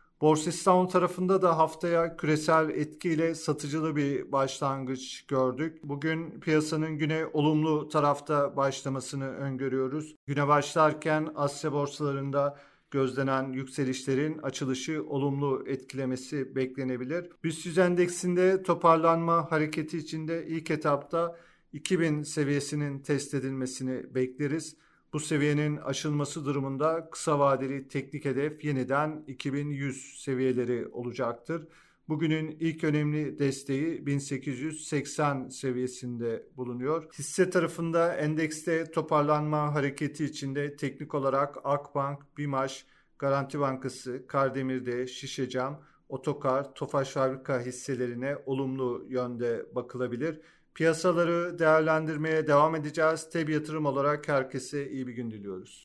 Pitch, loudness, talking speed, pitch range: 145 Hz, -29 LUFS, 100 wpm, 135-160 Hz